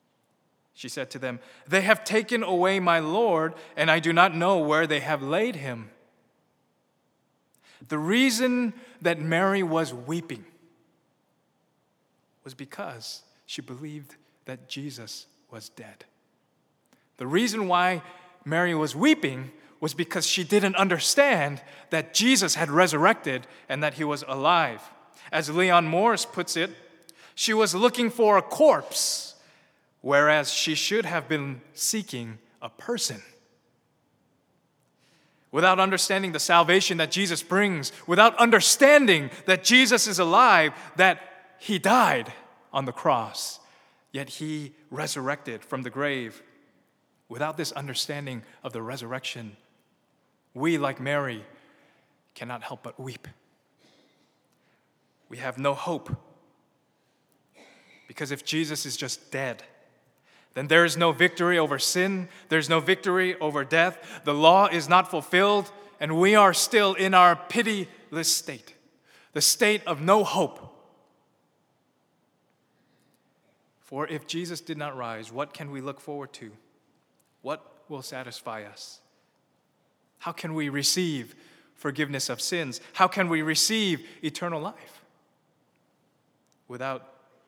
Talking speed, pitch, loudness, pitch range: 125 wpm, 165 Hz, -23 LUFS, 145-185 Hz